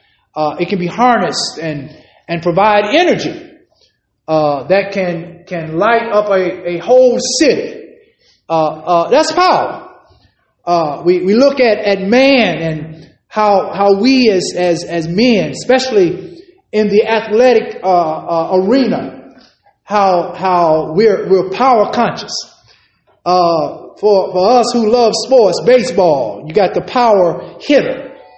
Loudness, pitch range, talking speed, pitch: -12 LUFS, 175-245 Hz, 135 wpm, 200 Hz